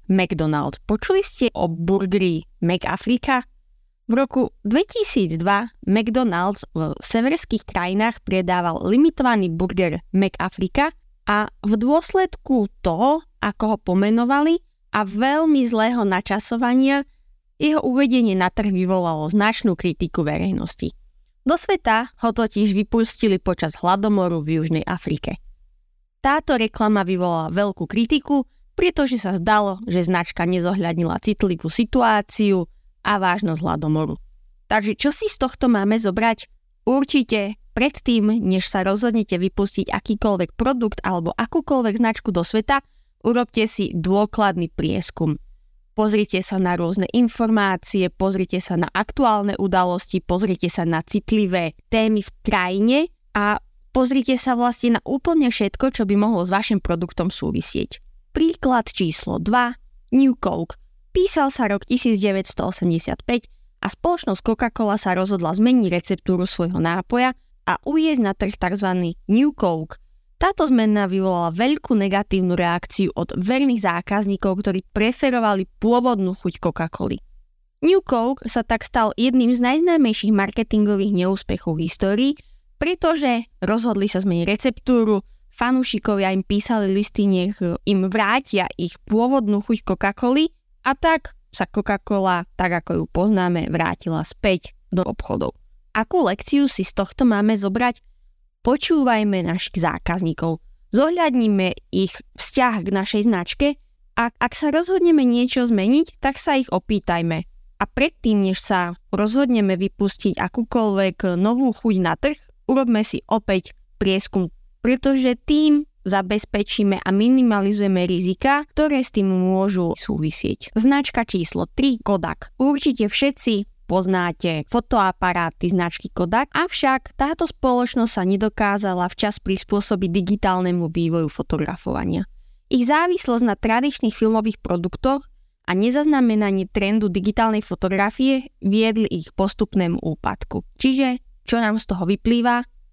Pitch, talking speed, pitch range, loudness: 210 Hz, 120 wpm, 185-245 Hz, -20 LUFS